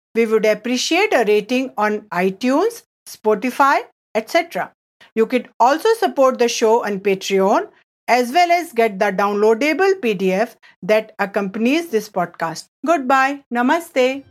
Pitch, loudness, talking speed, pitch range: 230 Hz, -18 LUFS, 125 wpm, 210-275 Hz